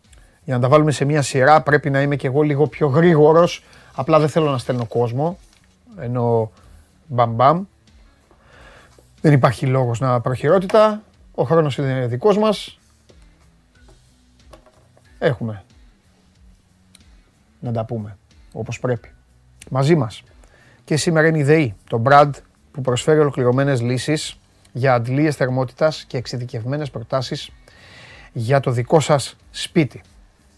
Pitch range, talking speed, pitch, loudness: 110-150 Hz, 125 wpm, 130 Hz, -18 LUFS